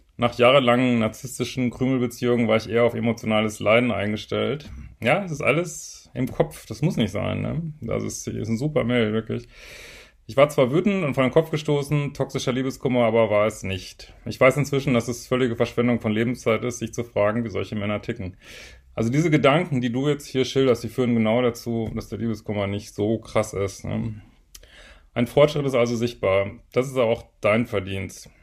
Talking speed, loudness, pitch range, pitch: 195 wpm, -23 LUFS, 110-130 Hz, 120 Hz